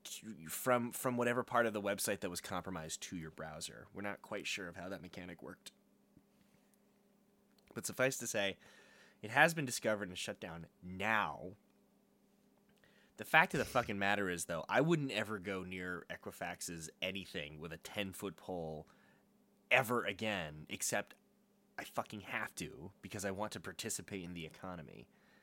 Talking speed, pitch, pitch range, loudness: 165 wpm, 105 Hz, 90-125 Hz, -38 LUFS